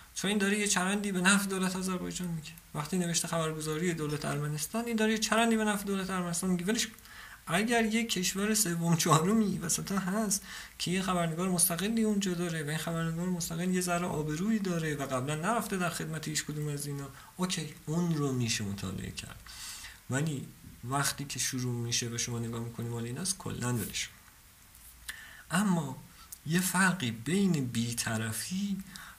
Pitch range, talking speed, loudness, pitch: 145-190 Hz, 155 wpm, -31 LUFS, 170 Hz